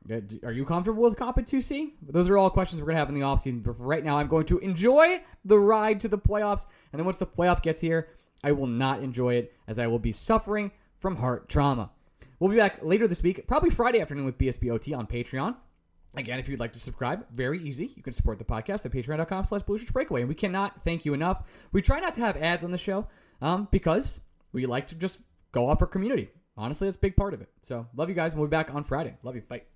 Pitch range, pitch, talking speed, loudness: 125-195 Hz, 160 Hz, 250 wpm, -27 LUFS